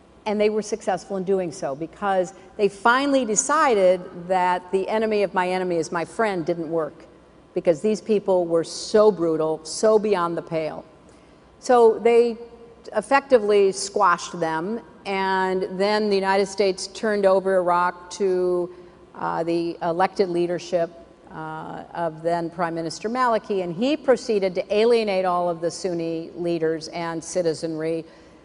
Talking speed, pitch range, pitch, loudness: 145 wpm, 170-210 Hz, 185 Hz, -22 LUFS